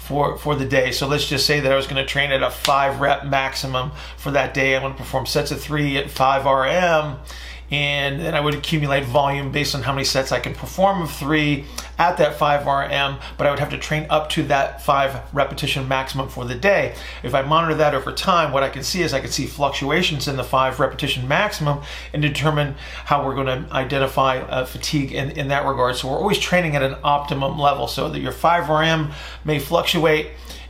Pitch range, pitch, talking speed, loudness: 135-150 Hz, 140 Hz, 215 wpm, -20 LUFS